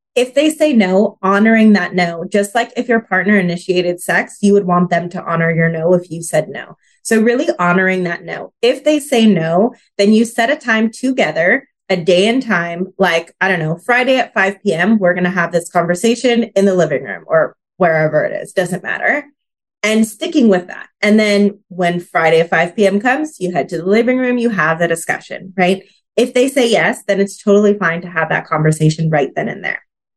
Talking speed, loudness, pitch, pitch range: 215 wpm, -14 LUFS, 195 Hz, 175-230 Hz